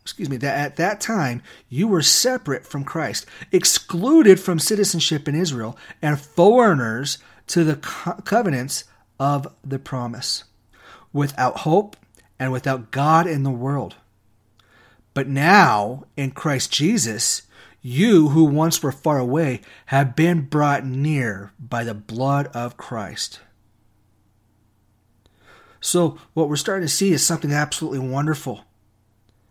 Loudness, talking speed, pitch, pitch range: -20 LUFS, 125 wpm, 140 Hz, 120-160 Hz